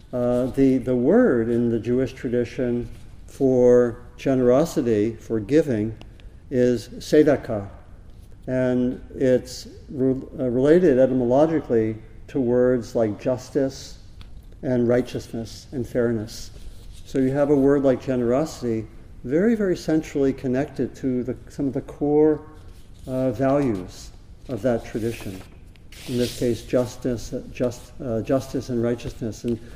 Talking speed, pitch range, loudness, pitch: 120 wpm, 110-130 Hz, -22 LUFS, 125 Hz